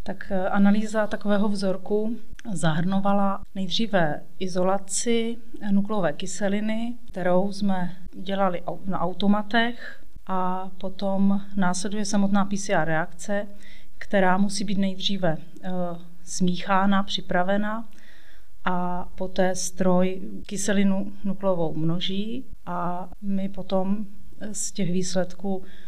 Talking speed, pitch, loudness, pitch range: 90 wpm, 195 Hz, -26 LUFS, 185-205 Hz